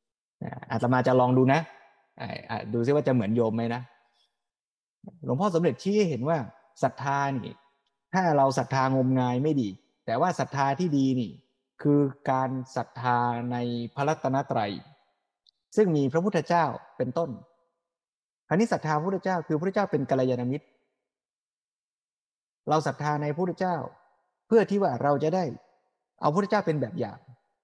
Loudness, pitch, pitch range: -27 LUFS, 140 Hz, 125-165 Hz